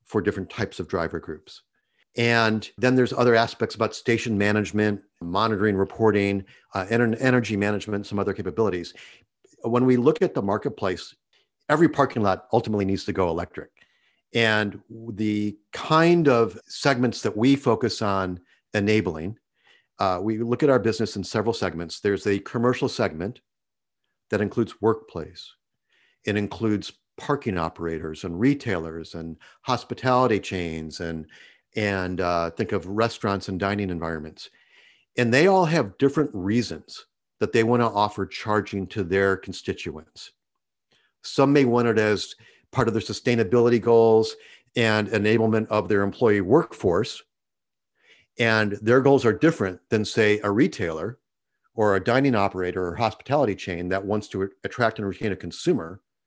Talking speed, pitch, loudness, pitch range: 145 wpm, 105 Hz, -23 LUFS, 95-115 Hz